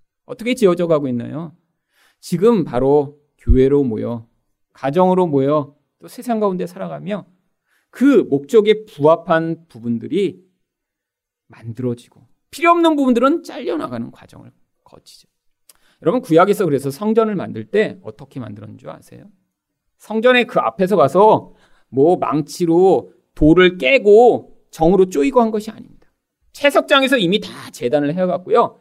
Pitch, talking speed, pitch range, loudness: 175 Hz, 300 characters per minute, 140-220 Hz, -16 LUFS